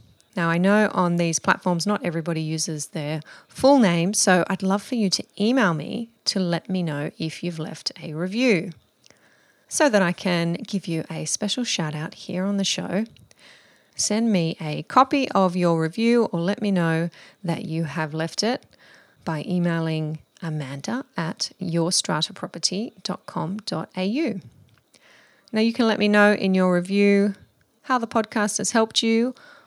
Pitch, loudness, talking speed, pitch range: 185 Hz, -23 LUFS, 160 wpm, 165-210 Hz